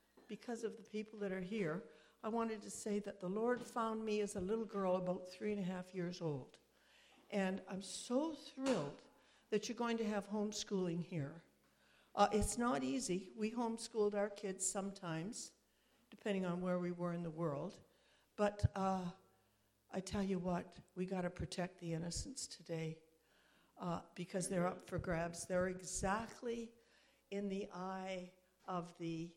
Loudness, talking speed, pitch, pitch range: -42 LUFS, 165 wpm, 195 Hz, 180-220 Hz